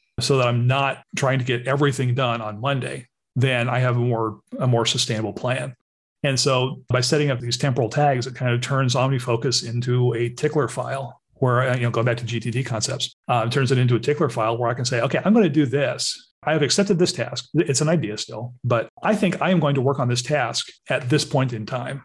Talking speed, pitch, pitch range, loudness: 240 wpm, 130 Hz, 120-140 Hz, -22 LUFS